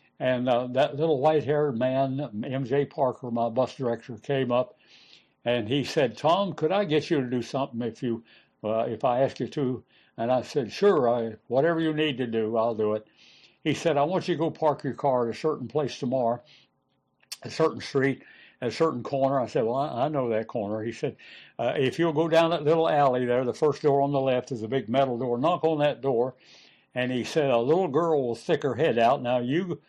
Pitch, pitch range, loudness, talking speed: 135 Hz, 120-150 Hz, -26 LUFS, 225 wpm